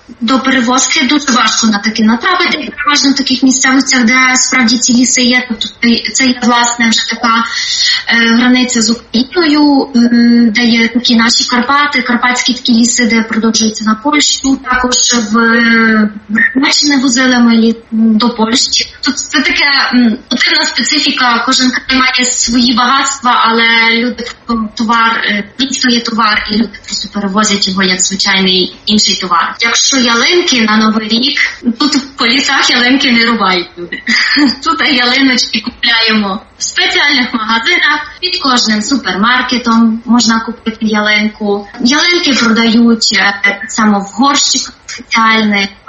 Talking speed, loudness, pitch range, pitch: 135 wpm, -9 LUFS, 225-265 Hz, 240 Hz